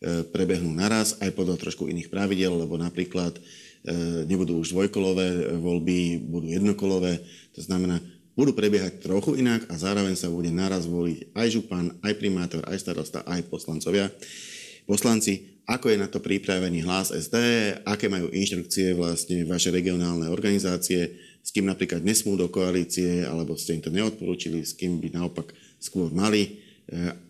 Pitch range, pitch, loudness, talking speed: 85-100 Hz, 90 Hz, -26 LUFS, 150 wpm